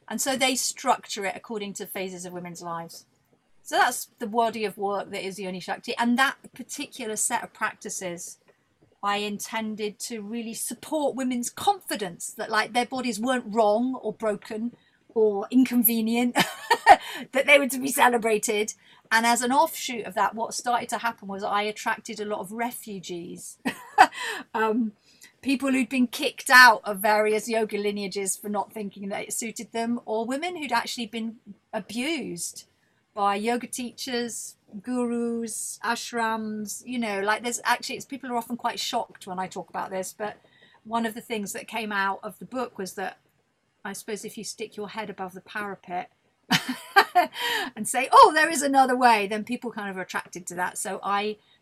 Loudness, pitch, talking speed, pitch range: -25 LUFS, 225 Hz, 175 wpm, 205-245 Hz